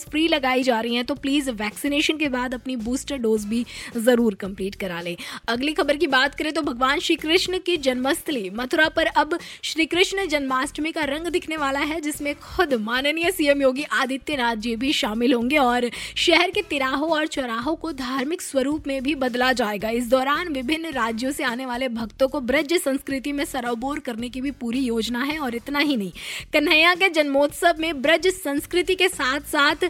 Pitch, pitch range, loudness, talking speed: 280 Hz, 250-315 Hz, -22 LUFS, 190 wpm